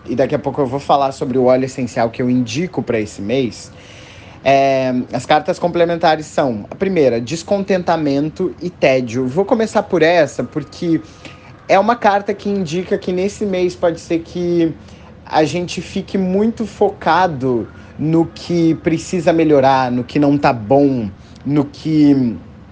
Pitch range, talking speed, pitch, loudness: 130-180 Hz, 155 wpm, 155 Hz, -16 LUFS